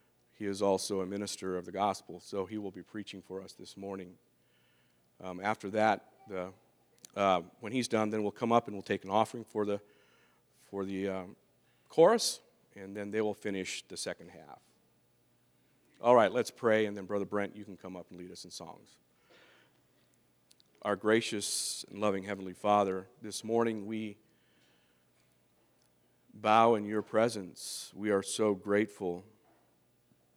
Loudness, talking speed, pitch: -33 LUFS, 160 wpm, 100 Hz